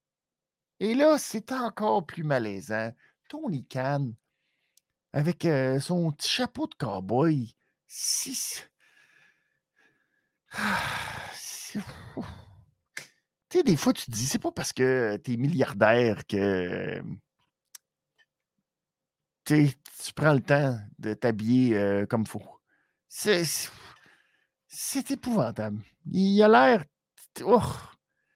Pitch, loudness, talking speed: 150 Hz, -27 LUFS, 100 wpm